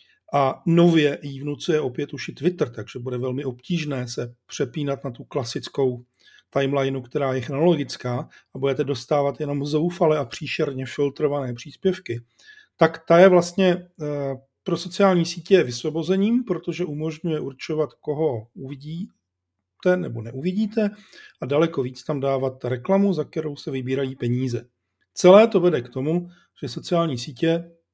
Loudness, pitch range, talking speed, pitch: -23 LUFS, 135-170 Hz, 135 wpm, 150 Hz